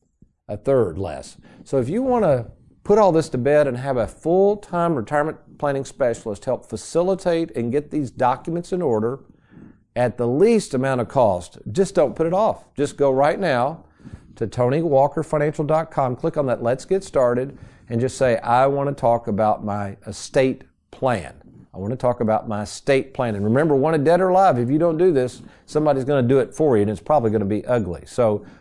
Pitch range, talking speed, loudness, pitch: 115-155 Hz, 205 wpm, -20 LUFS, 135 Hz